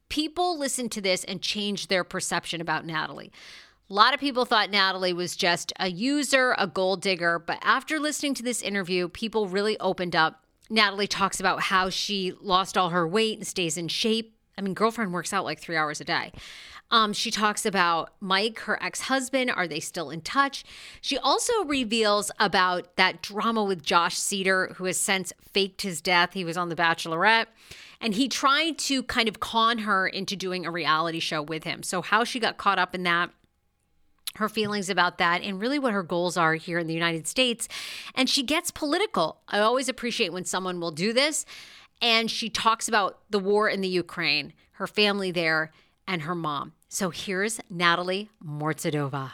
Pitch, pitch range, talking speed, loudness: 190 Hz, 175-225 Hz, 190 wpm, -25 LUFS